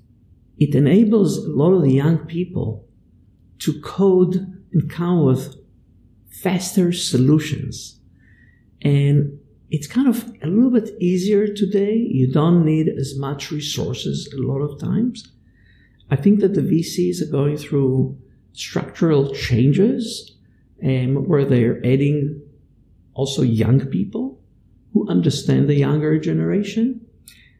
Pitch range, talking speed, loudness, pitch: 130-185 Hz, 125 wpm, -19 LUFS, 145 Hz